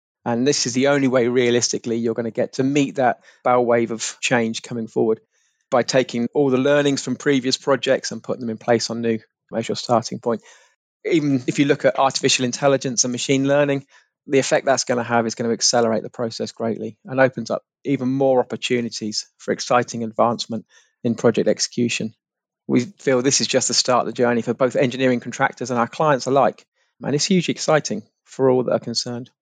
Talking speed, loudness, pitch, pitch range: 205 wpm, -20 LUFS, 125 Hz, 120-135 Hz